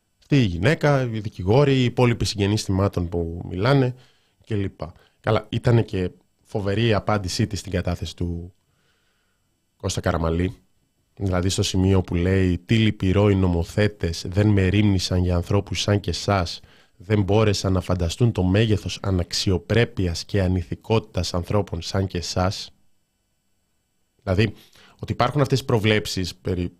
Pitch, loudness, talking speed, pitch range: 100 Hz, -22 LUFS, 135 wpm, 90-110 Hz